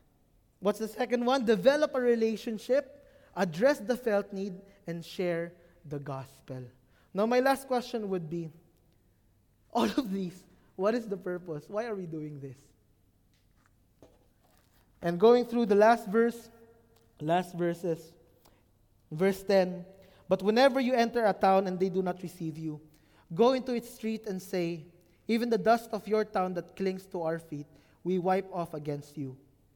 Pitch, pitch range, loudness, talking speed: 185 Hz, 155-220 Hz, -30 LUFS, 155 wpm